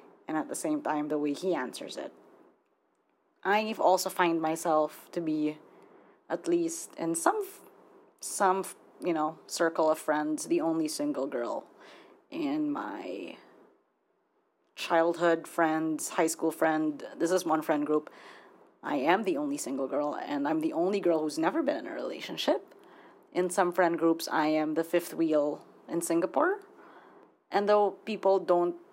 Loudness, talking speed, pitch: -30 LUFS, 160 wpm, 180 Hz